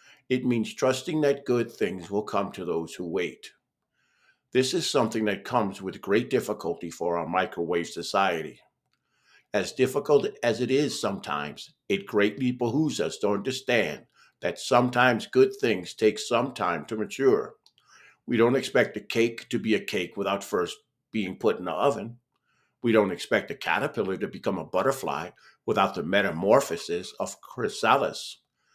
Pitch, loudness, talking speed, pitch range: 120 Hz, -27 LUFS, 155 wpm, 105-145 Hz